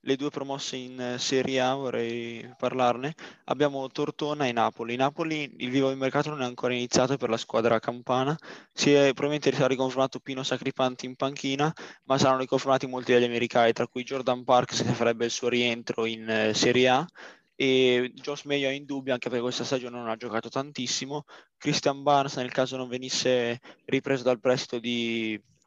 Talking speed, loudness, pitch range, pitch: 175 wpm, -27 LUFS, 120-135 Hz, 130 Hz